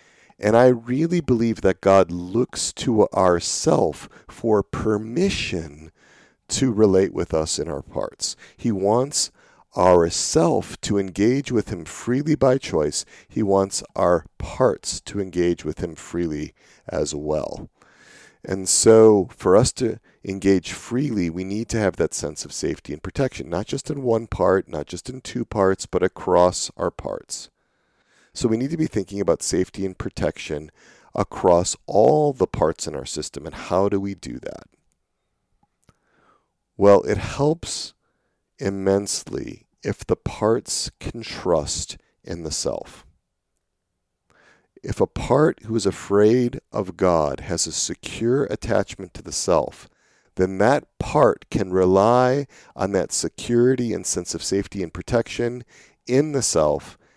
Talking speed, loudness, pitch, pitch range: 145 wpm, -21 LUFS, 100 Hz, 90-120 Hz